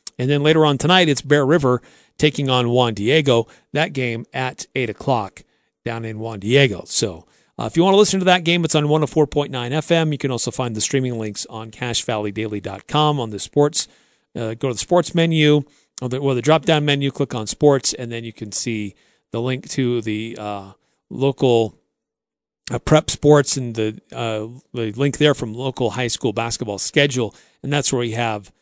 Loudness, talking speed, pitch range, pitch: -19 LUFS, 195 wpm, 115-145 Hz, 130 Hz